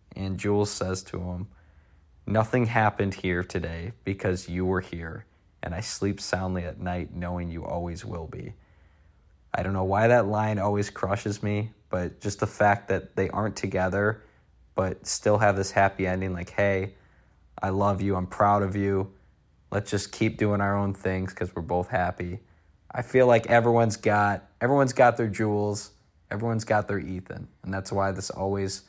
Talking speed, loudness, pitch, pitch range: 175 wpm, -27 LUFS, 95 Hz, 90-105 Hz